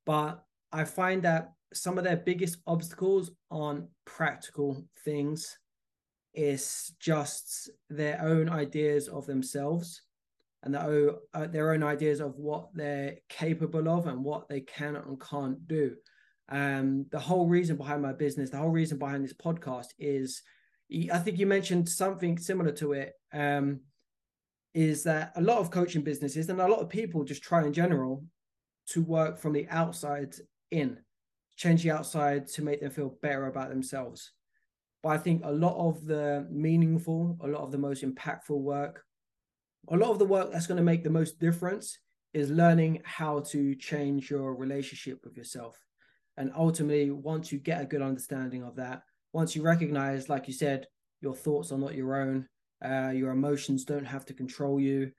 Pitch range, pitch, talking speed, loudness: 140-165 Hz, 150 Hz, 170 wpm, -31 LUFS